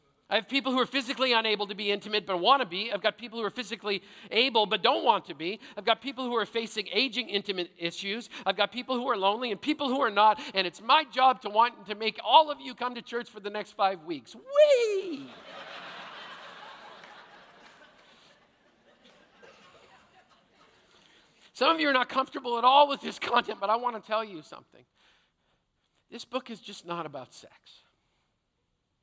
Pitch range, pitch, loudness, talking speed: 205-260 Hz, 230 Hz, -27 LUFS, 190 wpm